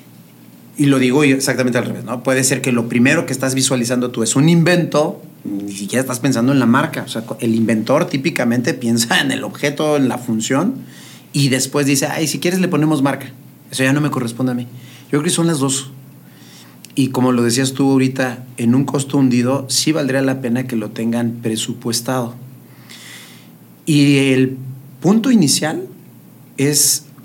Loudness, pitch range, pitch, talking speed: -16 LUFS, 120-140 Hz, 130 Hz, 185 wpm